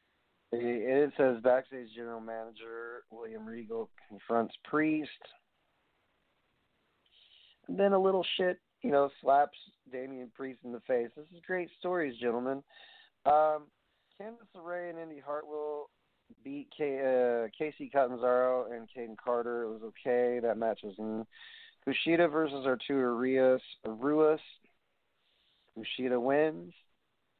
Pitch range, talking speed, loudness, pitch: 115-155 Hz, 120 wpm, -32 LUFS, 130 Hz